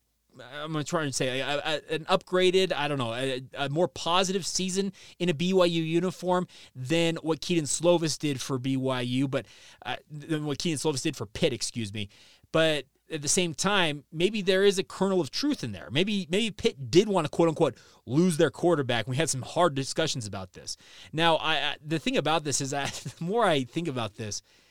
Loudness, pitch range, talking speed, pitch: -27 LUFS, 135-180 Hz, 210 wpm, 160 Hz